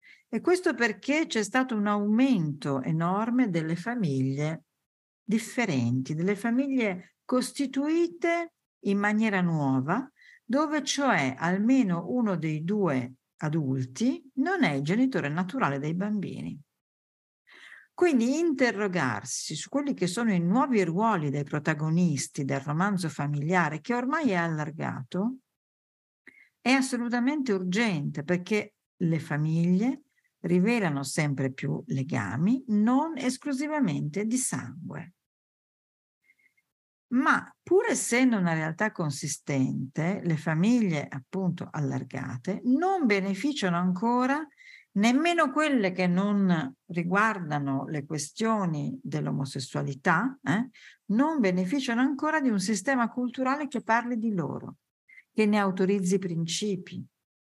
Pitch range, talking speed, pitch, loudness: 155-245 Hz, 105 wpm, 195 Hz, -27 LUFS